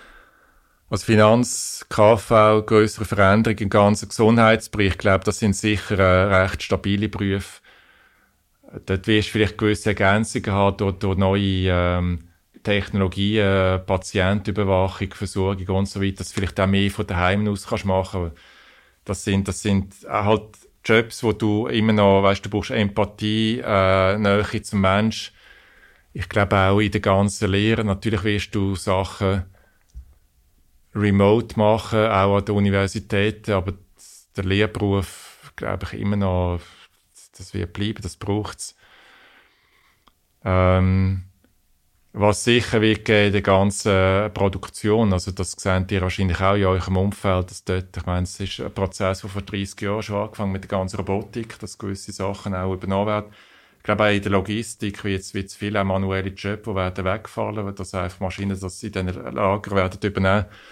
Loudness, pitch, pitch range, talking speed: -21 LUFS, 100 Hz, 95-105 Hz, 160 wpm